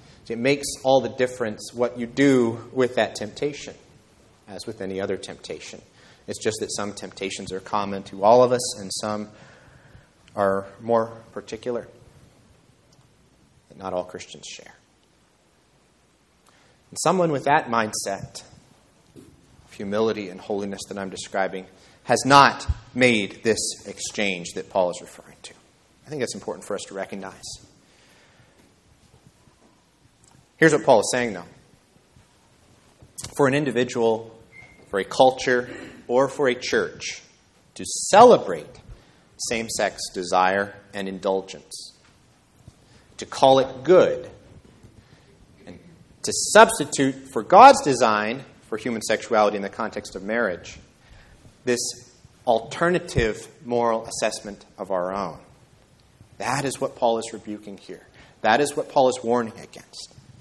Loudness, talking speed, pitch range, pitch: -22 LUFS, 125 wpm, 100-130 Hz, 115 Hz